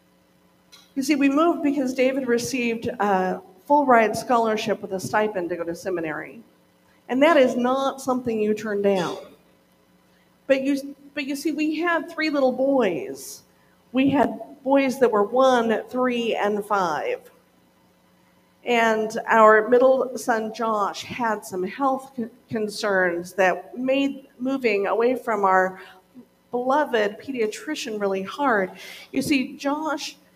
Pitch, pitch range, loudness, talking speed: 235 Hz, 200-270 Hz, -22 LUFS, 130 wpm